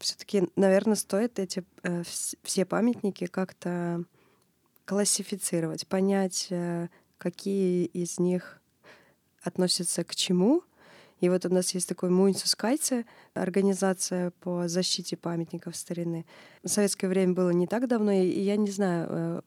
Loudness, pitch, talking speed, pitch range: -28 LUFS, 185 Hz, 125 wpm, 175-195 Hz